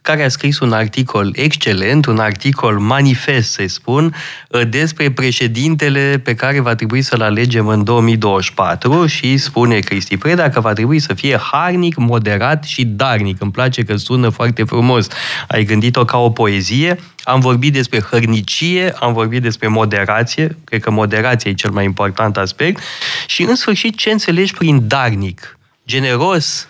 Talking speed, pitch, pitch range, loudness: 155 wpm, 120 Hz, 110-145 Hz, -14 LUFS